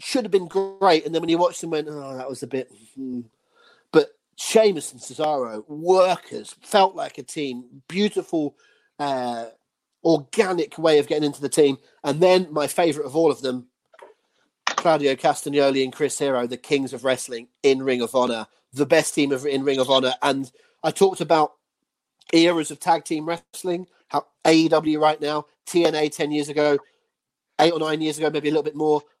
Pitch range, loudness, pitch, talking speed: 135-165 Hz, -22 LUFS, 150 Hz, 185 wpm